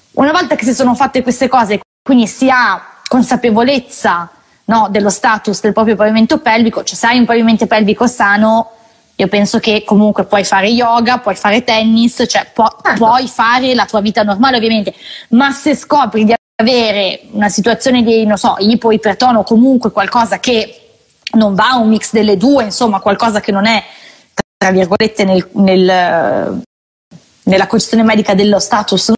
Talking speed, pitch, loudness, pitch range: 165 wpm, 225 Hz, -10 LUFS, 205-240 Hz